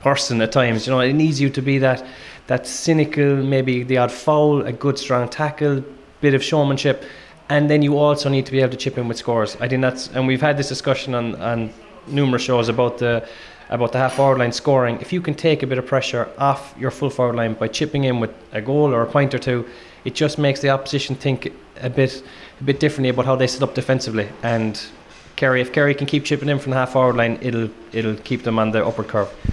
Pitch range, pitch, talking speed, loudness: 120-140 Hz, 130 Hz, 240 wpm, -19 LUFS